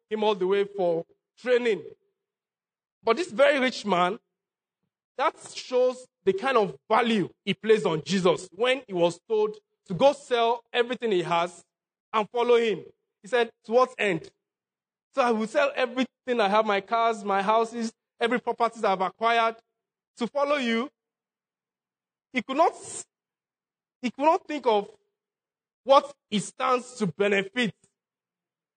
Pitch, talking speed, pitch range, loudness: 230 Hz, 150 wpm, 200-255 Hz, -26 LUFS